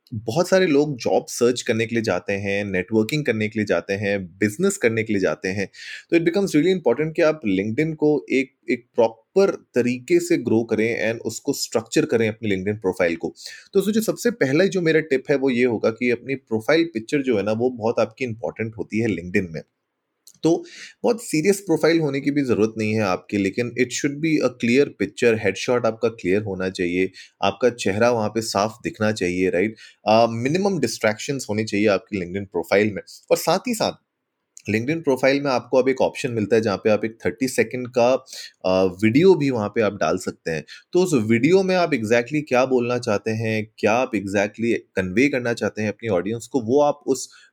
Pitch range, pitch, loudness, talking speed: 105-145 Hz, 120 Hz, -21 LUFS, 210 wpm